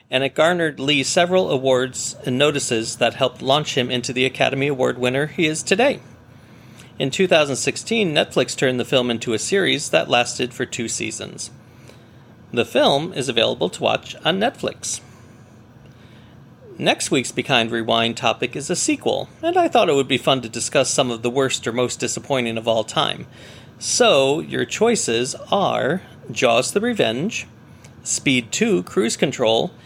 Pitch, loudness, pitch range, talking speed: 130 Hz, -19 LUFS, 120-145 Hz, 160 wpm